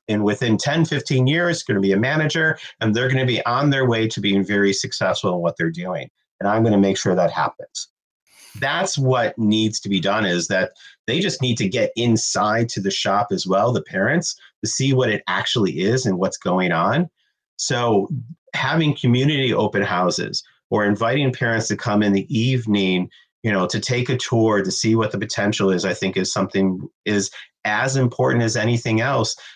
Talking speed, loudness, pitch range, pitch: 205 wpm, -20 LUFS, 100-130 Hz, 110 Hz